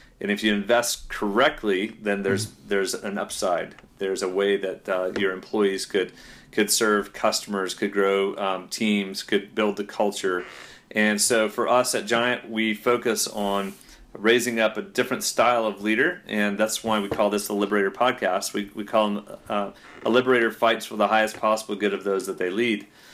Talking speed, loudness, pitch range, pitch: 185 wpm, -24 LUFS, 100-110 Hz, 105 Hz